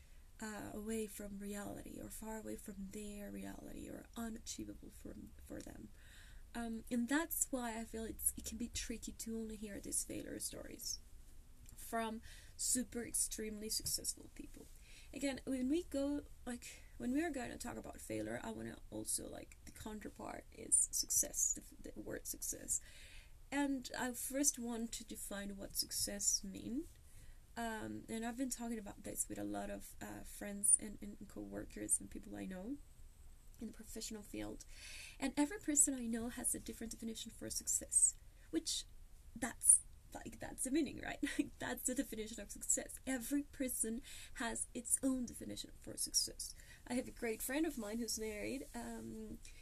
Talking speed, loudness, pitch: 165 wpm, -40 LUFS, 225 Hz